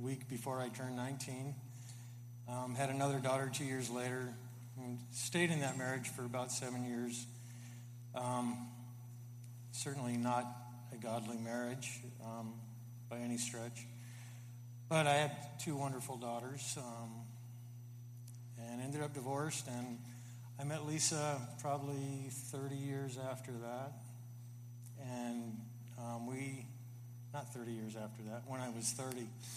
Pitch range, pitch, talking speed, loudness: 120-130 Hz, 120 Hz, 130 wpm, -42 LUFS